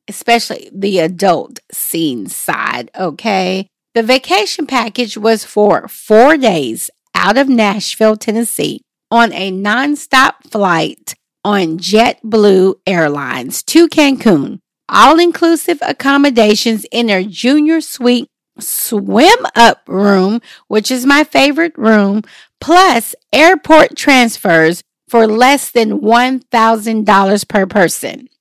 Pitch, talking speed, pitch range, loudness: 230 Hz, 105 wpm, 205-280 Hz, -11 LUFS